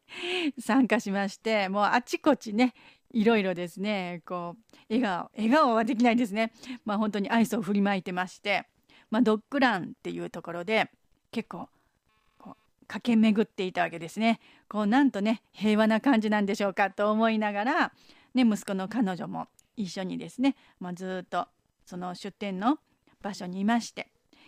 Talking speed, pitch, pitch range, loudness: 330 characters per minute, 215 Hz, 195-235 Hz, -28 LUFS